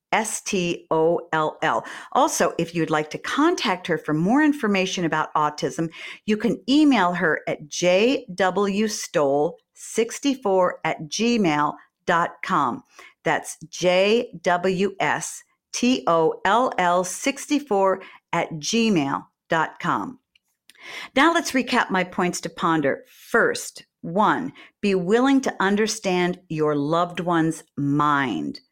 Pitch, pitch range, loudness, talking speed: 185 Hz, 165-235 Hz, -22 LUFS, 90 wpm